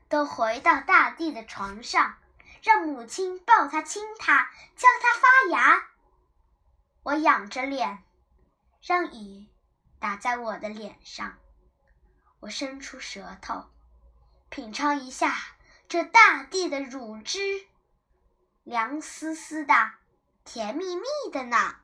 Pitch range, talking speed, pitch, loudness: 215-340 Hz, 150 characters per minute, 275 Hz, -24 LUFS